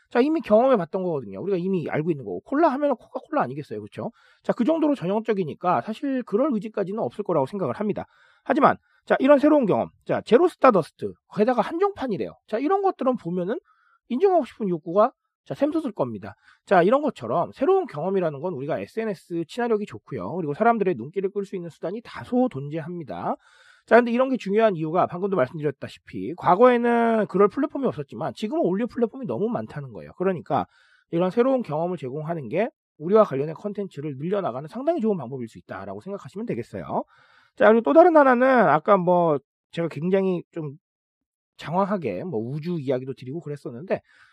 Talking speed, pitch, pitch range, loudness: 430 characters per minute, 205 Hz, 170-255 Hz, -23 LUFS